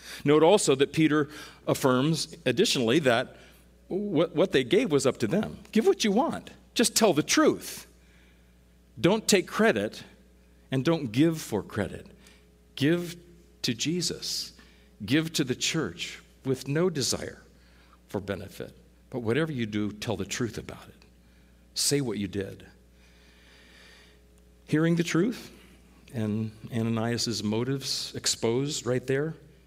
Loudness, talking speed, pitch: -27 LUFS, 130 wpm, 120 Hz